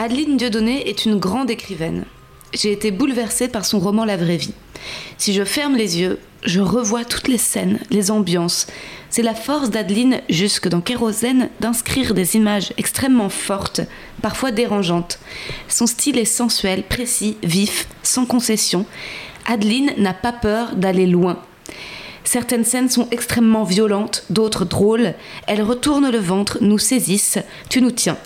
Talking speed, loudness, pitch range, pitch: 150 wpm, -18 LUFS, 195-240 Hz, 220 Hz